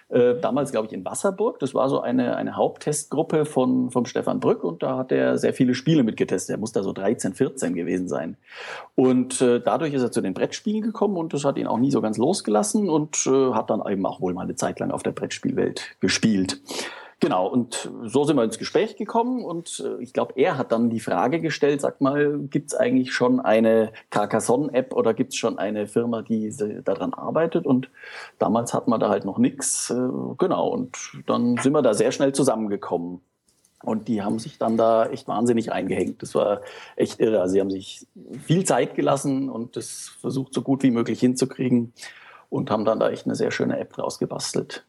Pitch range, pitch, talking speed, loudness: 115-145 Hz, 125 Hz, 205 wpm, -23 LUFS